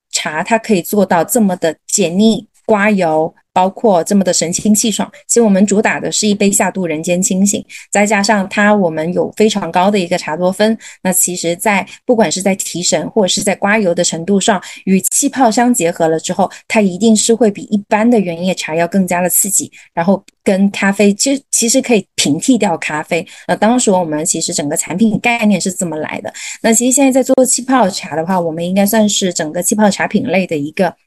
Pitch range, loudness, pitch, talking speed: 175-220 Hz, -13 LUFS, 200 Hz, 315 characters per minute